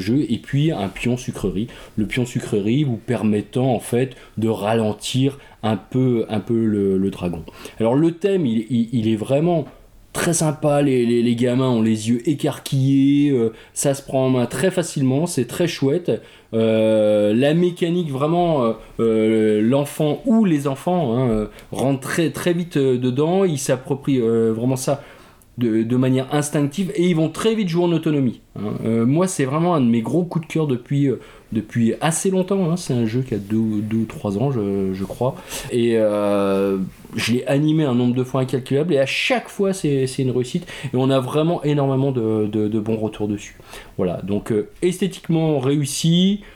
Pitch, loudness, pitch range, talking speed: 130 Hz, -20 LUFS, 110-150 Hz, 195 wpm